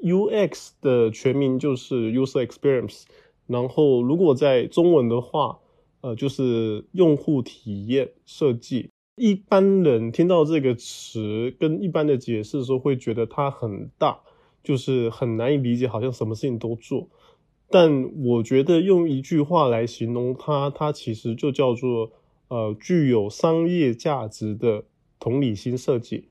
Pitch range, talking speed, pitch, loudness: 115-150 Hz, 245 characters per minute, 130 Hz, -22 LUFS